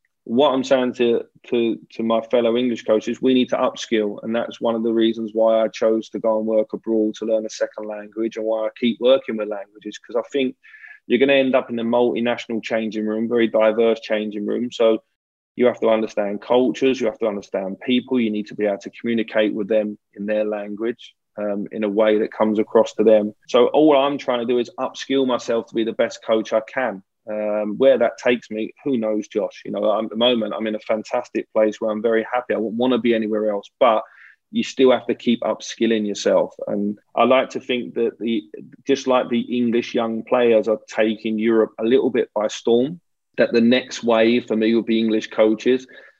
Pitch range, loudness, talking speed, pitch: 110-120 Hz, -20 LUFS, 225 wpm, 115 Hz